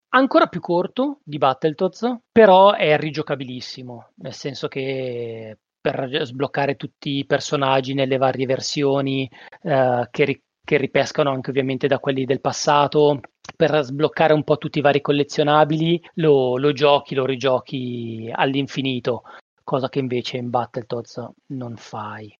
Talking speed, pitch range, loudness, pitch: 135 wpm, 130-150 Hz, -20 LUFS, 140 Hz